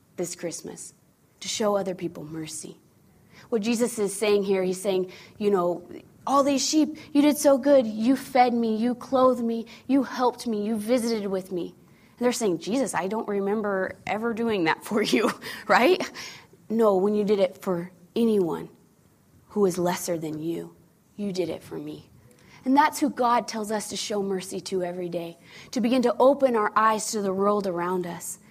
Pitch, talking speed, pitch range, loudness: 205 Hz, 185 wpm, 180-235 Hz, -25 LUFS